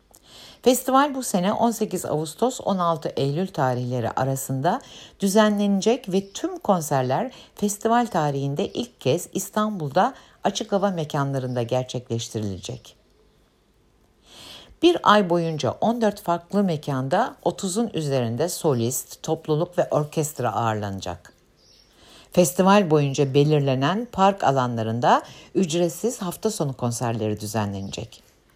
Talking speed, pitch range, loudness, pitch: 95 wpm, 130-200 Hz, -23 LUFS, 160 Hz